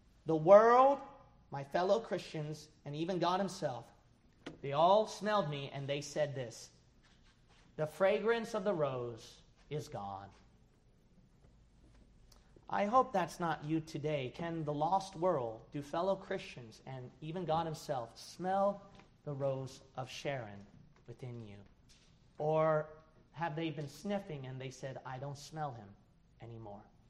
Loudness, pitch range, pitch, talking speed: -35 LUFS, 130-180 Hz, 150 Hz, 135 wpm